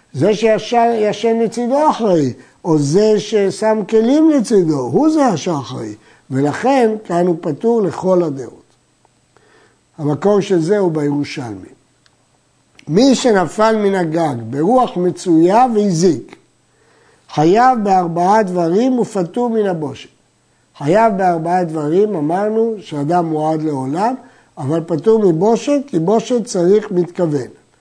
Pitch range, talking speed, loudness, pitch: 160-225 Hz, 110 wpm, -15 LUFS, 185 Hz